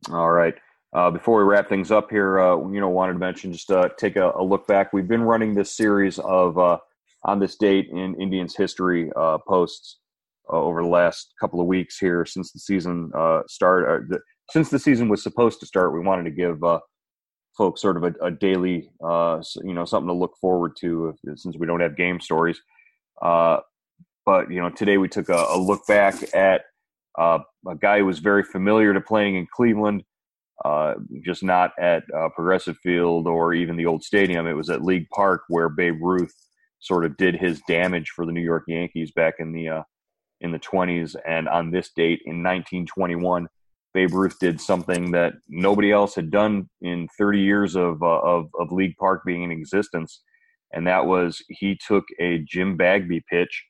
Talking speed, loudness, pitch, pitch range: 200 wpm, -22 LUFS, 90 Hz, 85-95 Hz